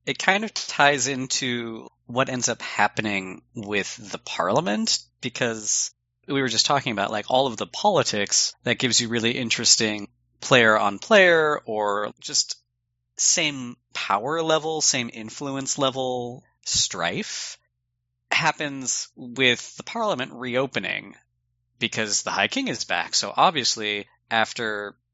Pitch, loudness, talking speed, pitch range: 120 Hz, -22 LUFS, 130 wpm, 110-135 Hz